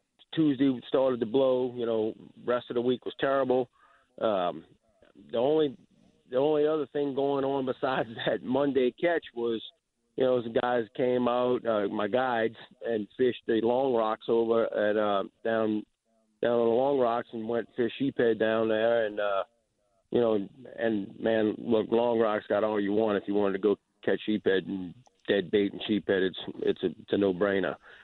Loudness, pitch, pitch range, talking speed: -28 LUFS, 115 Hz, 110-130 Hz, 185 wpm